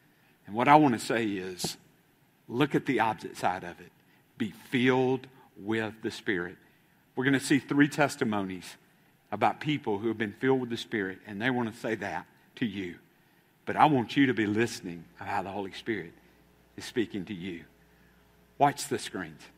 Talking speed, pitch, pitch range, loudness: 185 wpm, 110 Hz, 95-130 Hz, -29 LUFS